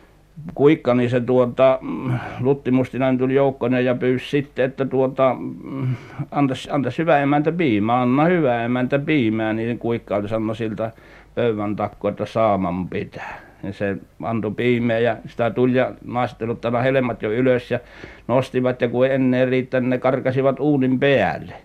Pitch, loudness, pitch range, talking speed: 125 Hz, -20 LUFS, 115-130 Hz, 145 wpm